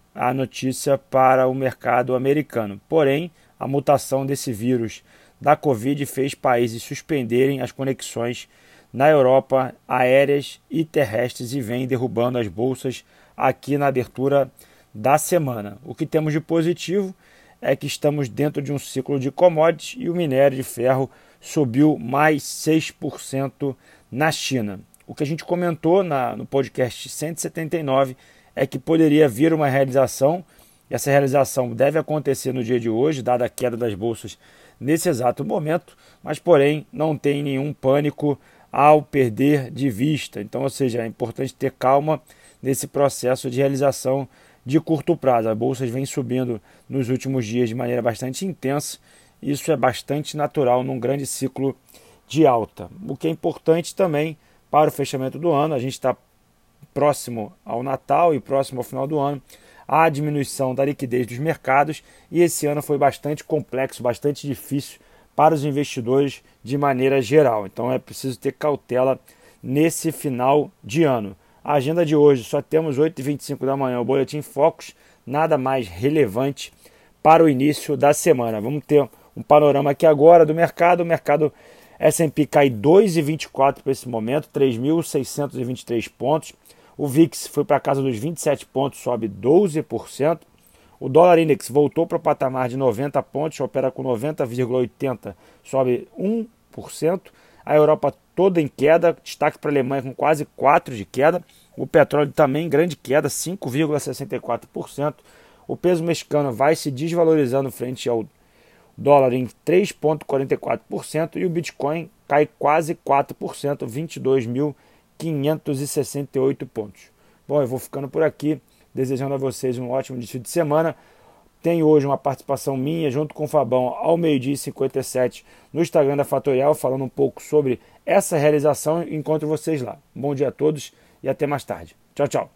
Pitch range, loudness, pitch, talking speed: 130-150 Hz, -21 LUFS, 140 Hz, 155 wpm